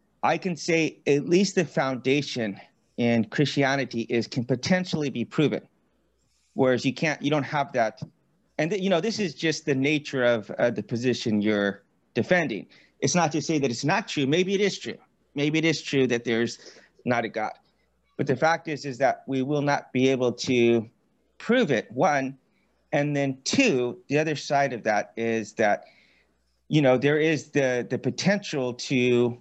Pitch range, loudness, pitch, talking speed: 120-155 Hz, -25 LUFS, 140 Hz, 185 wpm